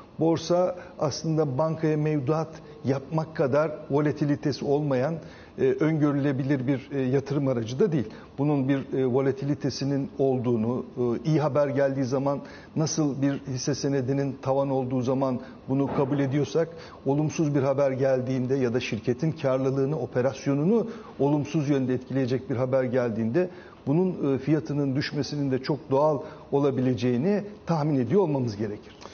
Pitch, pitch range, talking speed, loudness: 140 Hz, 130-155 Hz, 120 wpm, -26 LUFS